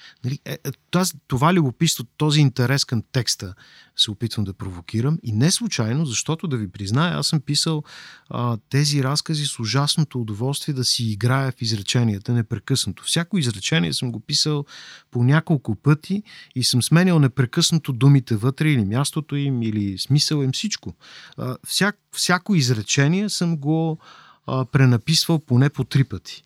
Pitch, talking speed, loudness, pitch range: 140 Hz, 145 wpm, -21 LUFS, 120-155 Hz